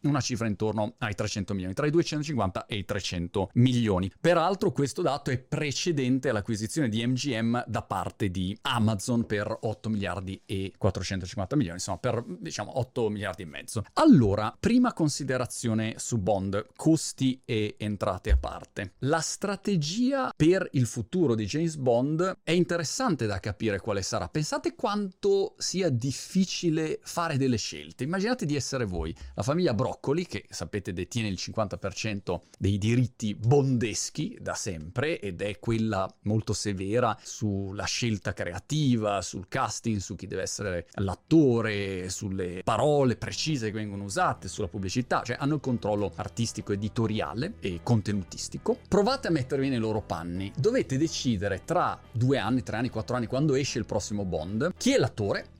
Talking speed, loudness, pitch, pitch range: 150 wpm, -28 LUFS, 115 Hz, 100-145 Hz